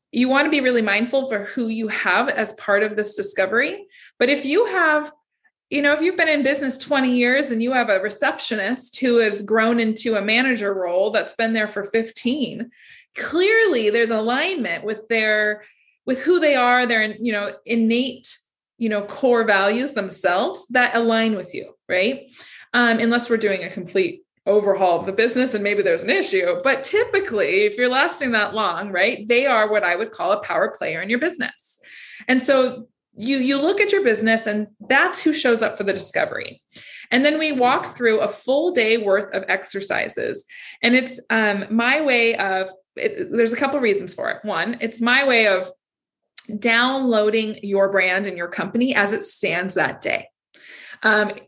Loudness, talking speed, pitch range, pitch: -19 LUFS, 190 wpm, 210-275 Hz, 235 Hz